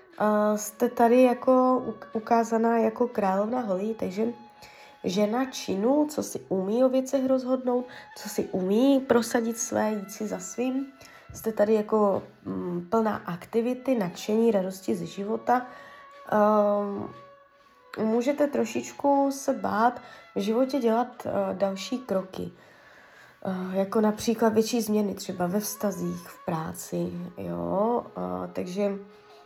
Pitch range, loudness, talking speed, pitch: 195-250 Hz, -27 LUFS, 120 wpm, 220 Hz